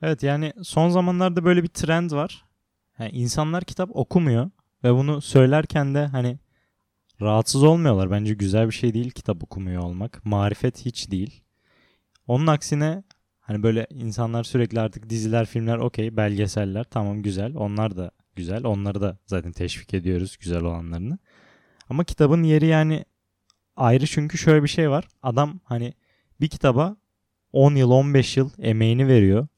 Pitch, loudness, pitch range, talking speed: 120 Hz, -22 LUFS, 105-150 Hz, 150 wpm